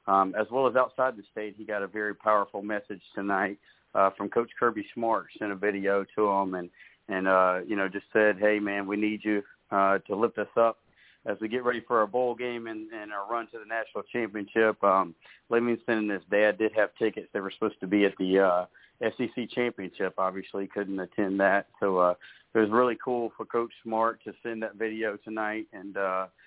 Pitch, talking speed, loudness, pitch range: 105 Hz, 215 wpm, -28 LUFS, 100-115 Hz